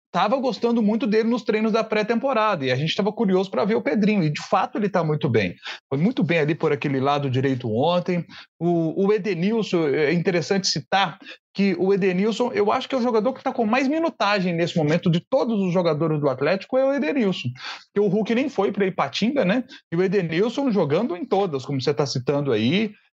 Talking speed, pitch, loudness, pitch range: 215 wpm, 195 Hz, -22 LUFS, 165-225 Hz